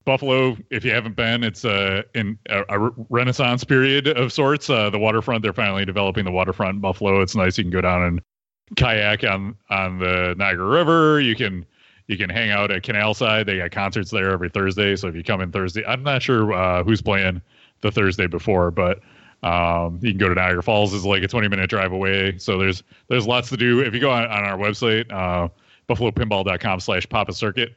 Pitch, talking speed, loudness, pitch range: 105 Hz, 215 wpm, -20 LUFS, 95-115 Hz